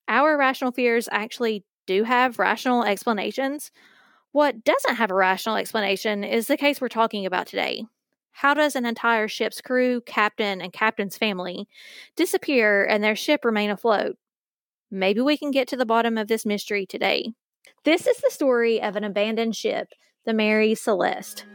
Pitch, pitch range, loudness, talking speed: 225 Hz, 210-260 Hz, -23 LUFS, 165 wpm